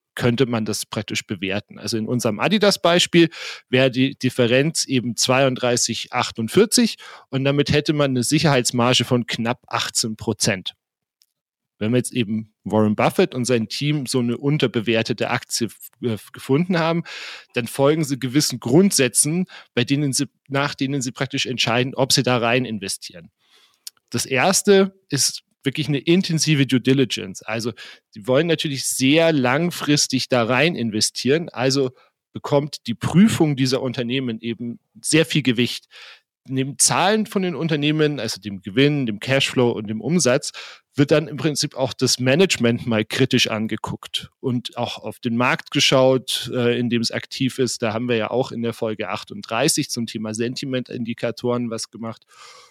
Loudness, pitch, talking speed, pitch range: -20 LUFS, 130 Hz, 150 wpm, 115-145 Hz